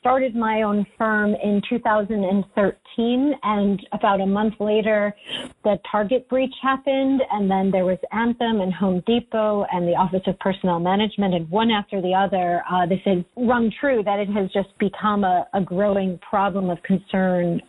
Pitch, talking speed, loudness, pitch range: 205 Hz, 170 wpm, -21 LUFS, 190-220 Hz